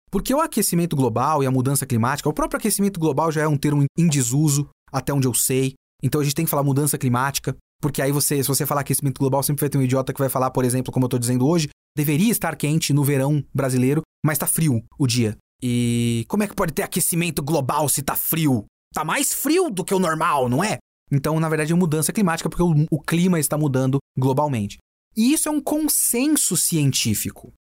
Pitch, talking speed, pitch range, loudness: 145 Hz, 220 wpm, 135-170 Hz, -21 LUFS